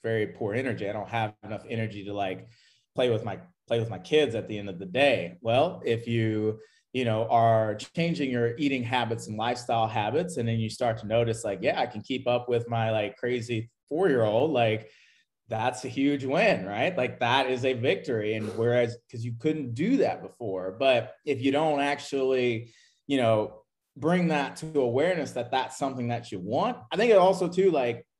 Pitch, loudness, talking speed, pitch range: 120 Hz, -27 LUFS, 200 wpm, 110-135 Hz